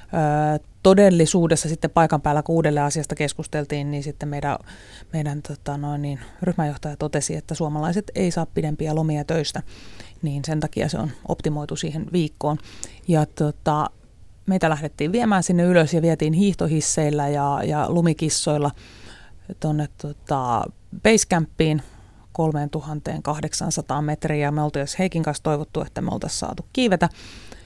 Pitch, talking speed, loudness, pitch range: 155 Hz, 130 wpm, -22 LUFS, 145-165 Hz